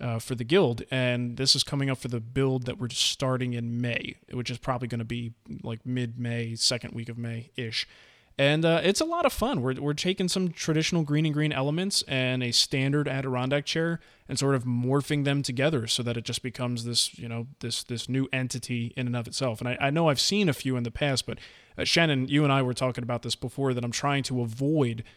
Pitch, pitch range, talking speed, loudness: 130 Hz, 120-145 Hz, 240 wpm, -27 LUFS